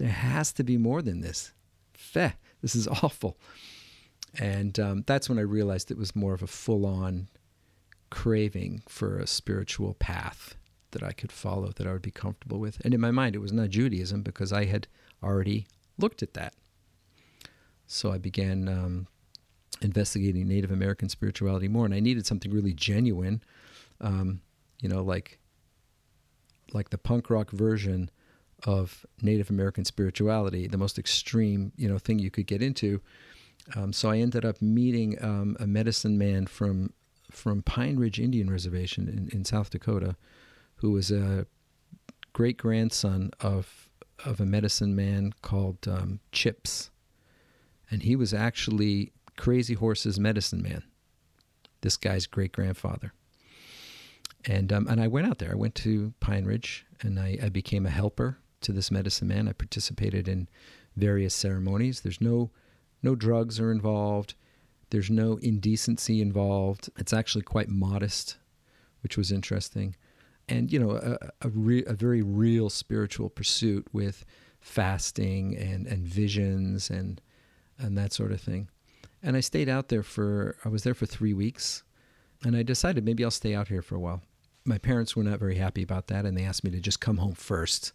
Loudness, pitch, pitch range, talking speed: -29 LUFS, 105 Hz, 95-115 Hz, 165 wpm